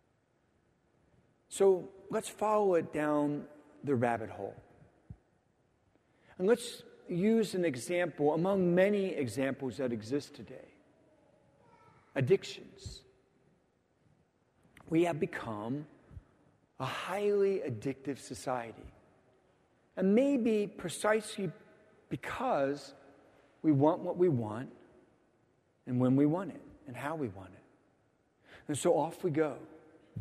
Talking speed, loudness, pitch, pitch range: 100 wpm, -33 LUFS, 150 Hz, 130-185 Hz